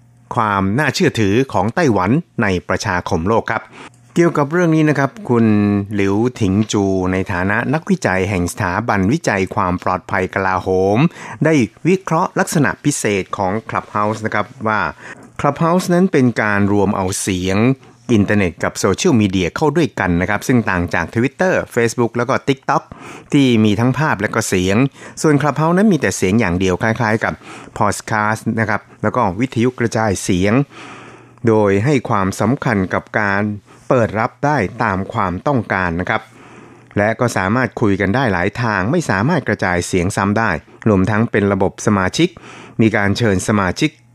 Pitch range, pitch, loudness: 100-130 Hz, 110 Hz, -16 LUFS